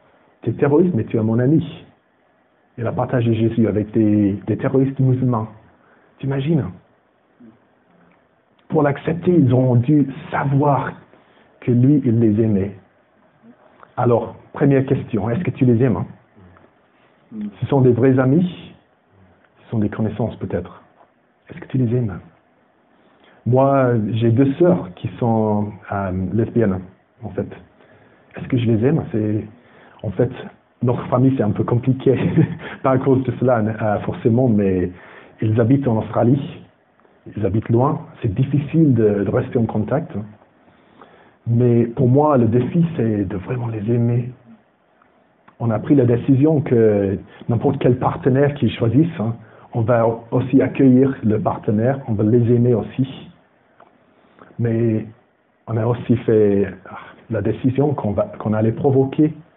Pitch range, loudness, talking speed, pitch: 110-135 Hz, -18 LUFS, 140 wpm, 120 Hz